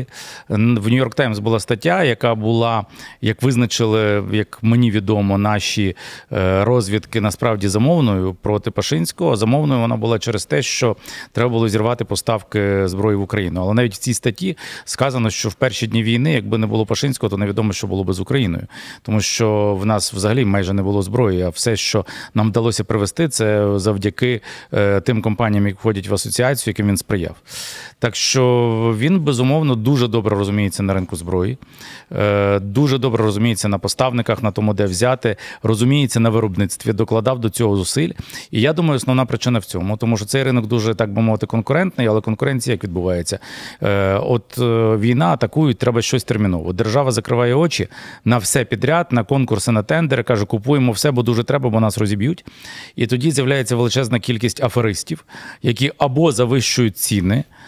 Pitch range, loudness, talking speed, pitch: 105-125 Hz, -18 LUFS, 170 wpm, 115 Hz